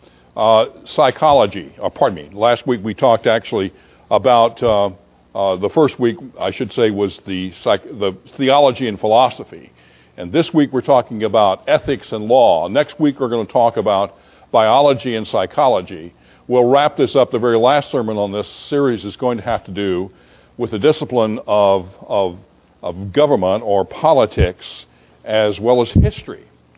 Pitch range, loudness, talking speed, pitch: 95-130 Hz, -16 LUFS, 170 wpm, 110 Hz